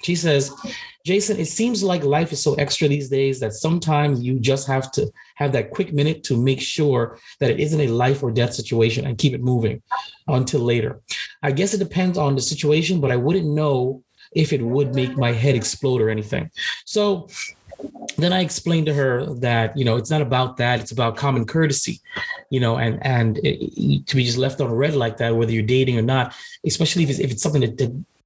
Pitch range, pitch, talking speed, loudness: 125-155 Hz, 140 Hz, 220 wpm, -21 LUFS